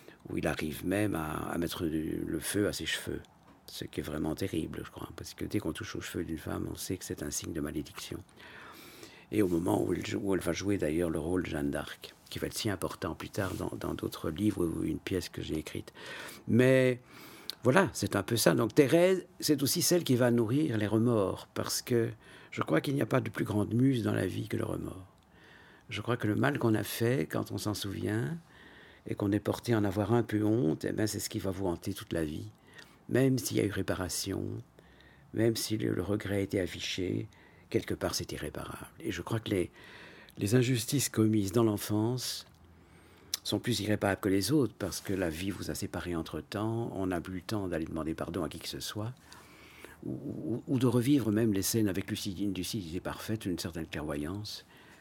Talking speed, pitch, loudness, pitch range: 225 wpm, 105 Hz, -32 LUFS, 90-115 Hz